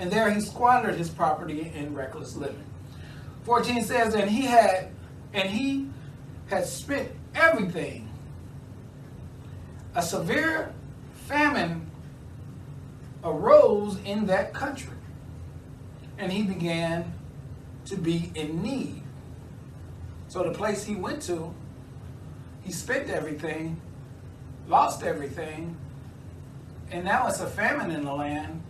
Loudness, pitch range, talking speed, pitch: -26 LUFS, 135-210 Hz, 110 wpm, 165 Hz